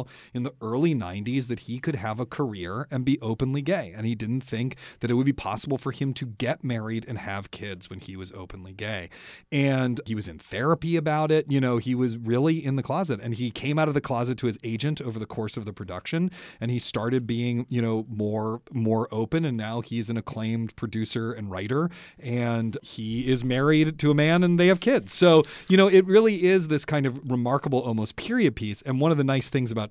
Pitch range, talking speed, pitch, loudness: 110-145 Hz, 230 wpm, 125 Hz, -25 LUFS